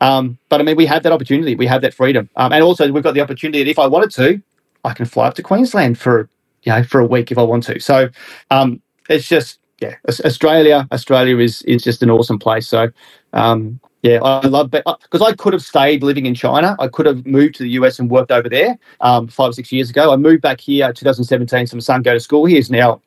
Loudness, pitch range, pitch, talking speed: -13 LUFS, 120-150 Hz, 130 Hz, 255 wpm